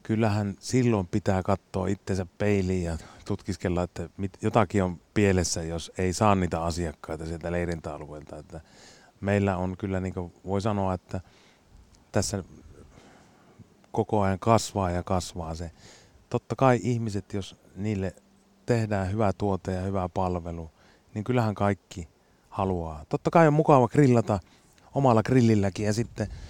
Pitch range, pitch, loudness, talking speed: 90-105 Hz, 95 Hz, -27 LUFS, 135 wpm